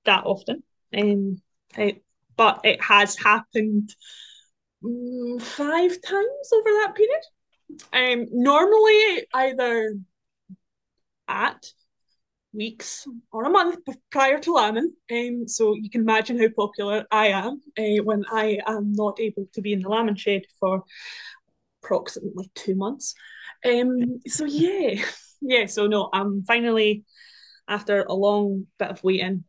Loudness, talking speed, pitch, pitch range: -22 LUFS, 125 wpm, 220 Hz, 205-270 Hz